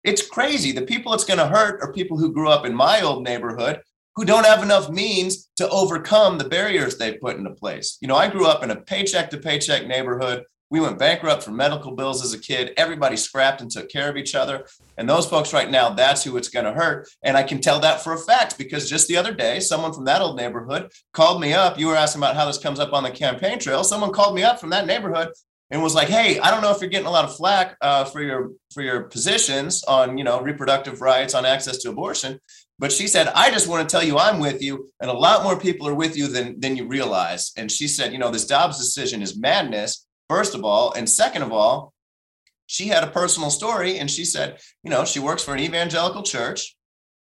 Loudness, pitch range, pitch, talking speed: -20 LUFS, 135-185 Hz, 150 Hz, 245 wpm